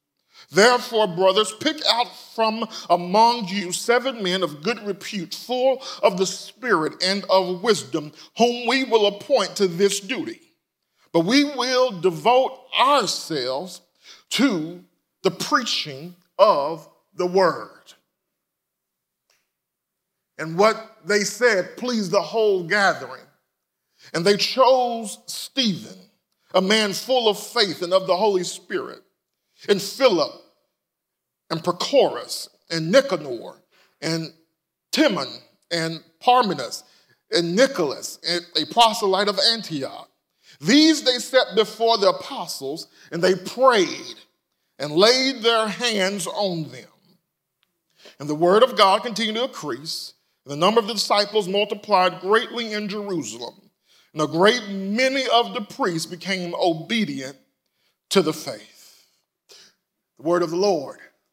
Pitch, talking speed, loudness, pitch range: 200 Hz, 125 wpm, -21 LUFS, 180-235 Hz